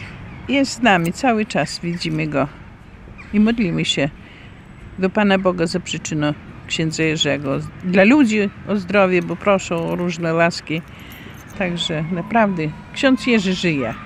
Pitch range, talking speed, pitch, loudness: 155-200 Hz, 130 wpm, 175 Hz, -19 LUFS